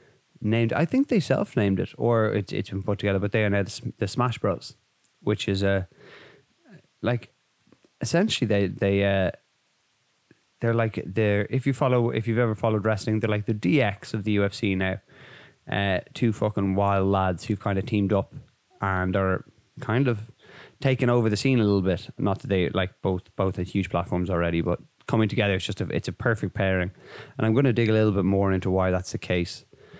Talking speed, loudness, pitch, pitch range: 205 wpm, -25 LUFS, 105 Hz, 95-115 Hz